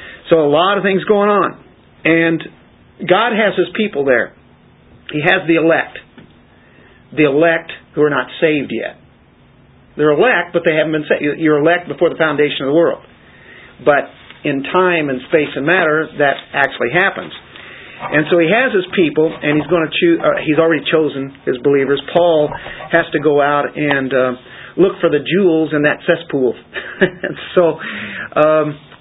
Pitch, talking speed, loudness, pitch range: 155 Hz, 170 wpm, -14 LUFS, 145-170 Hz